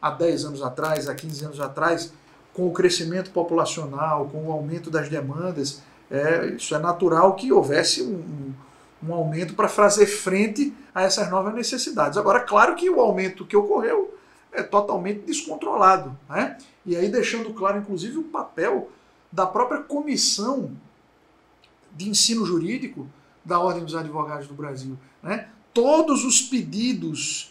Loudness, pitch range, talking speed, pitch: -23 LUFS, 155-230 Hz, 150 wpm, 185 Hz